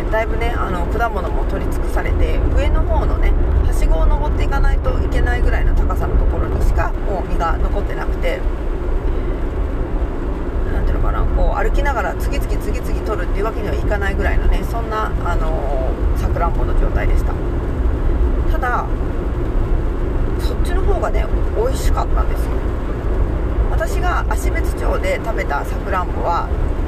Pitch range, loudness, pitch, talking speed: 65-85 Hz, -20 LUFS, 70 Hz, 295 characters per minute